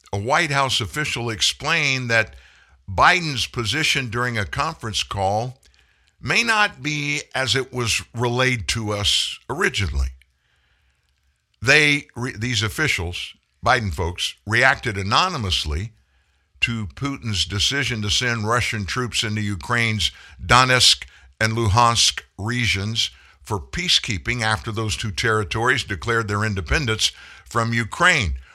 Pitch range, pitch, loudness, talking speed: 100-125 Hz, 115 Hz, -20 LUFS, 115 wpm